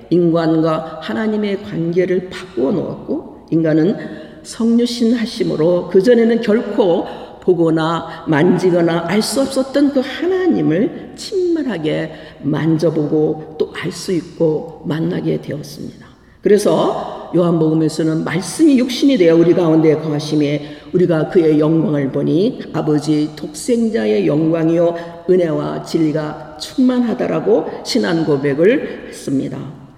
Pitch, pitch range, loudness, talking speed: 170 Hz, 155-215 Hz, -16 LUFS, 280 characters per minute